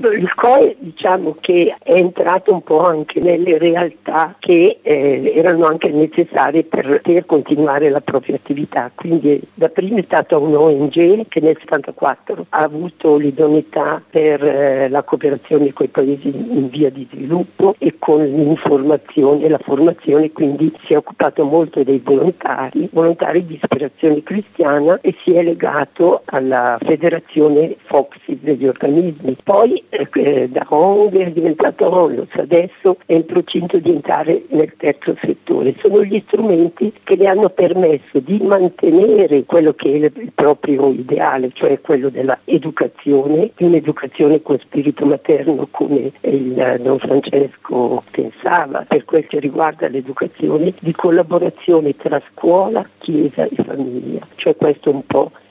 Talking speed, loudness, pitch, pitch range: 145 wpm, -15 LUFS, 155 Hz, 145-175 Hz